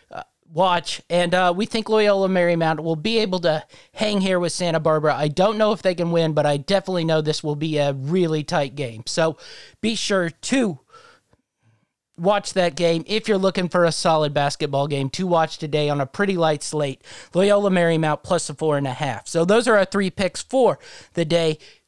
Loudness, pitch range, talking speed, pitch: -21 LUFS, 155-195 Hz, 205 wpm, 170 Hz